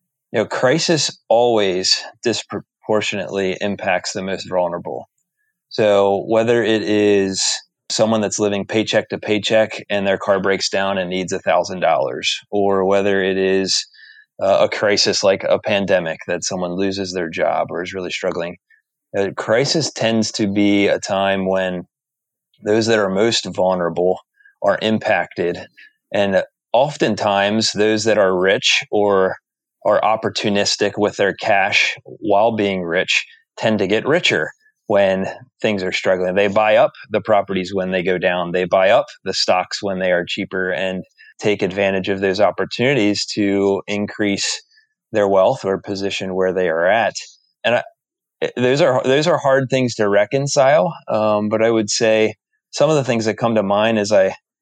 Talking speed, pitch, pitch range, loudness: 160 wpm, 105 Hz, 95-110 Hz, -18 LUFS